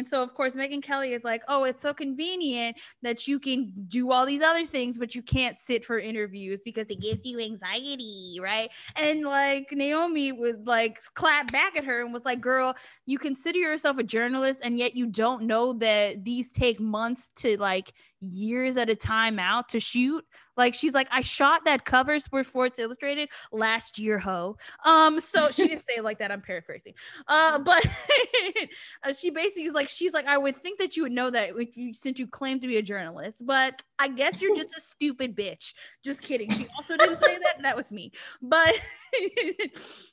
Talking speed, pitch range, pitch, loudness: 200 wpm, 230-295 Hz, 255 Hz, -26 LUFS